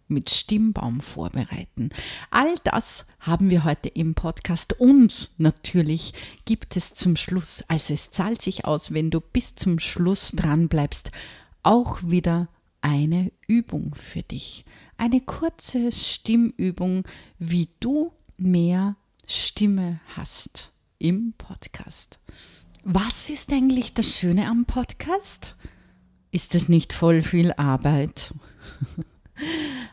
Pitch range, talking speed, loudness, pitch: 165-230 Hz, 115 wpm, -23 LUFS, 180 Hz